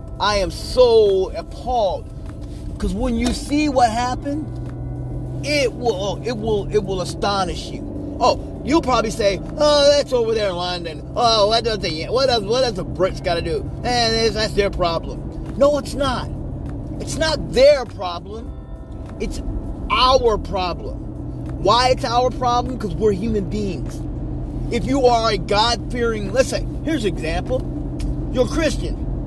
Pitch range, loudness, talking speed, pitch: 180-285 Hz, -20 LUFS, 160 wpm, 240 Hz